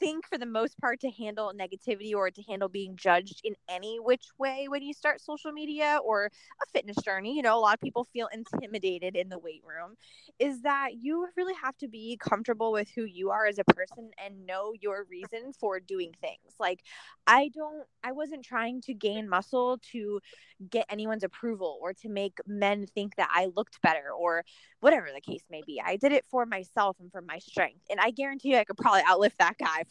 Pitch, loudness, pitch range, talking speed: 220 Hz, -30 LUFS, 195-260 Hz, 215 wpm